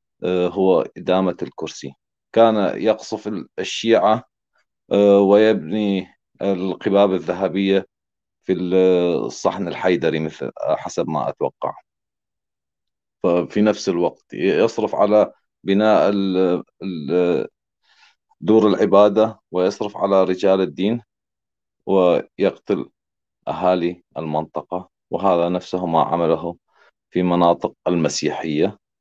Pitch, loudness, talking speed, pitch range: 95 Hz, -19 LUFS, 80 wpm, 90-100 Hz